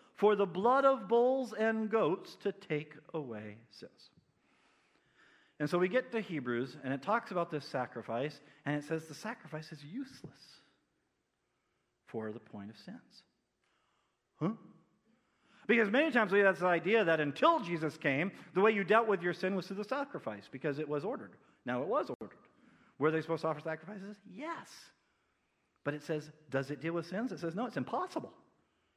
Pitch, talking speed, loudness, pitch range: 175 Hz, 180 wpm, -34 LUFS, 150-220 Hz